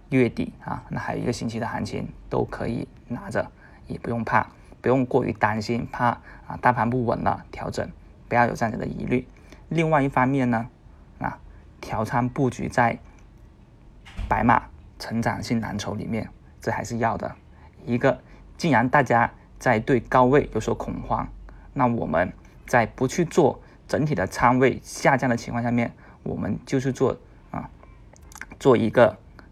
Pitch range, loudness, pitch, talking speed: 110-130 Hz, -24 LUFS, 120 Hz, 230 characters per minute